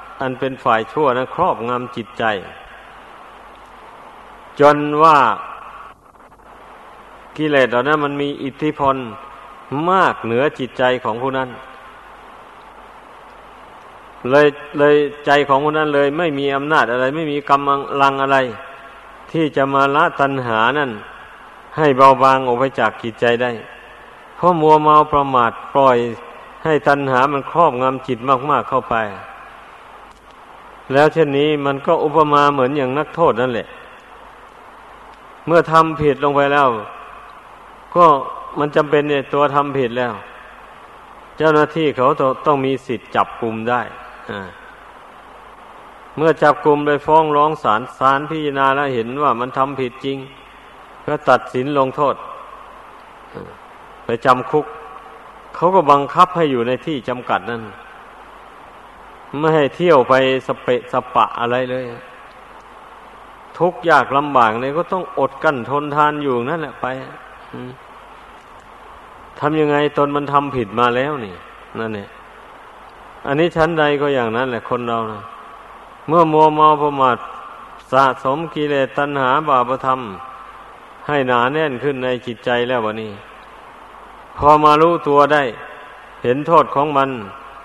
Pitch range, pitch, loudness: 125-150 Hz, 140 Hz, -16 LUFS